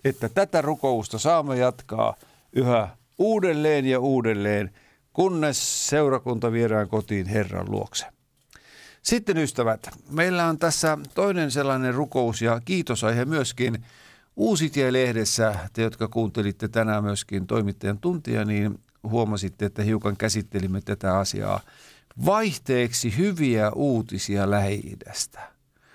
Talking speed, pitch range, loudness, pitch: 105 wpm, 105-145 Hz, -24 LUFS, 115 Hz